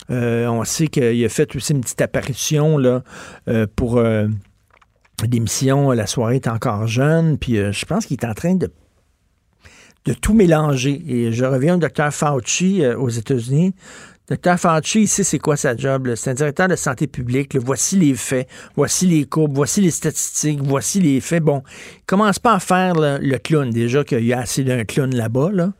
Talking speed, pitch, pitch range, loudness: 200 wpm, 140 Hz, 120-155 Hz, -18 LUFS